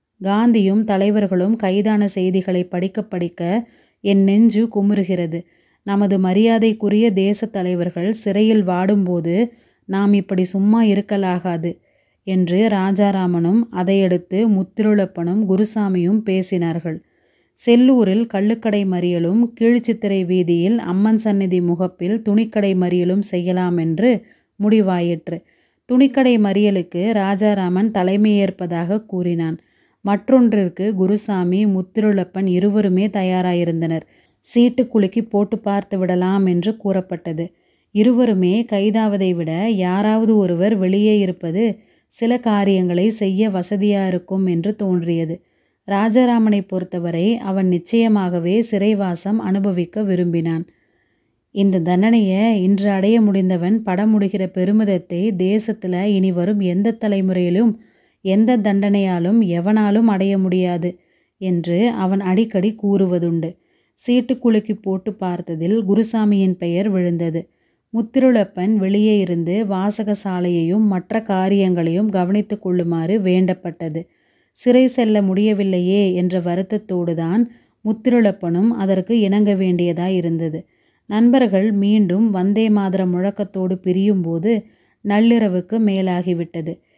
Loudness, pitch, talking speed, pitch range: -17 LUFS, 195 Hz, 90 wpm, 180-215 Hz